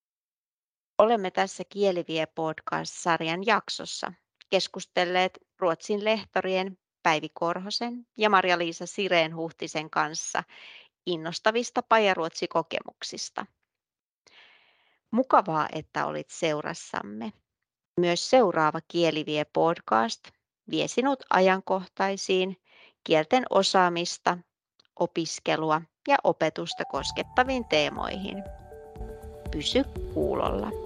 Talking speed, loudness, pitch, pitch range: 70 wpm, -27 LUFS, 180 Hz, 160-205 Hz